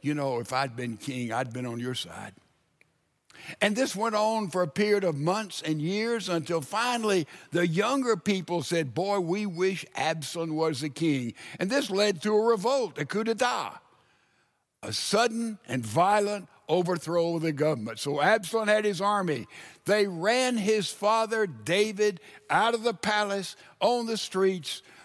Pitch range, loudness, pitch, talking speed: 155-215 Hz, -28 LUFS, 190 Hz, 165 wpm